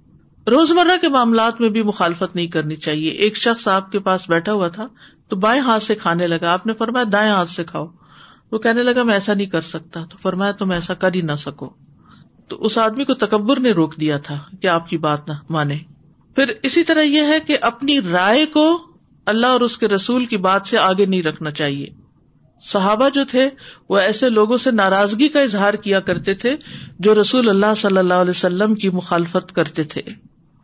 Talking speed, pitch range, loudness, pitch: 210 wpm, 170-235 Hz, -17 LUFS, 200 Hz